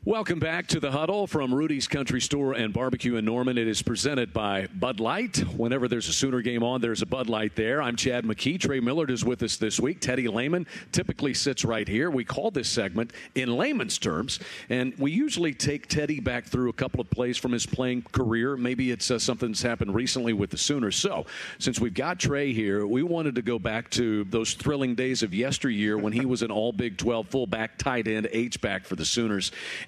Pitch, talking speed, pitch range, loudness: 125 Hz, 220 wpm, 115-135 Hz, -27 LUFS